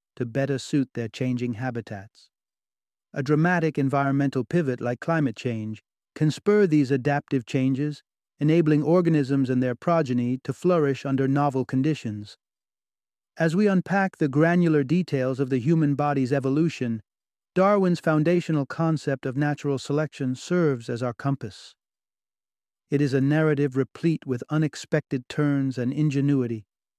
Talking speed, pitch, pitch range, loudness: 130 wpm, 140 Hz, 130-155 Hz, -24 LUFS